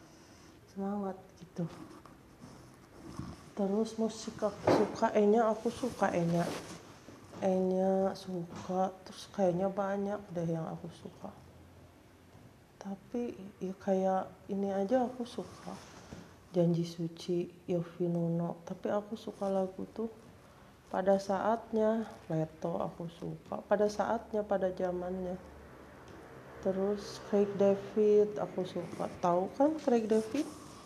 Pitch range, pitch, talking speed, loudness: 175-210 Hz, 195 Hz, 100 wpm, -34 LUFS